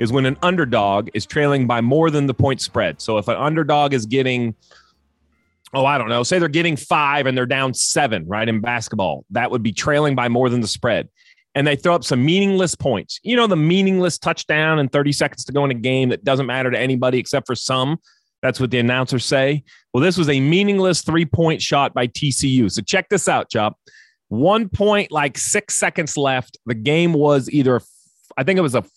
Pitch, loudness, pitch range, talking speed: 140 Hz, -18 LUFS, 125-165 Hz, 215 wpm